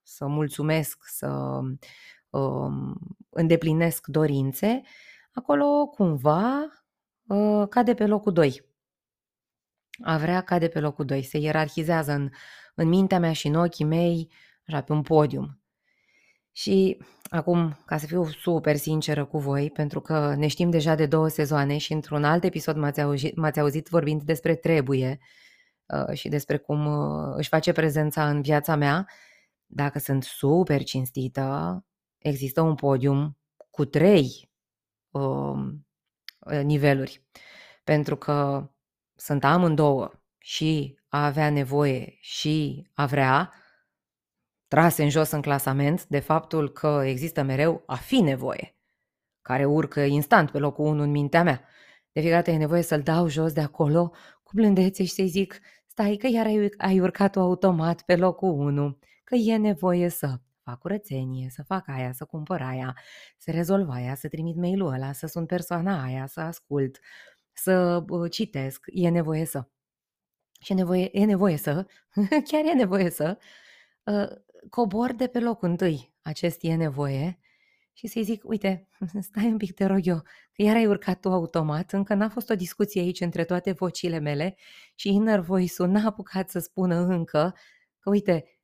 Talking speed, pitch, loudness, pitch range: 155 wpm, 160 Hz, -25 LUFS, 145-185 Hz